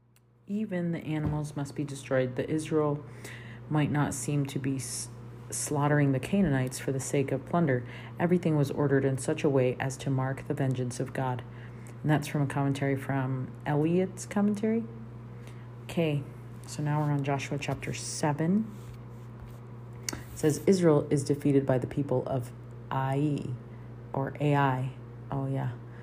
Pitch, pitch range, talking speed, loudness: 135 Hz, 120-150 Hz, 150 wpm, -30 LUFS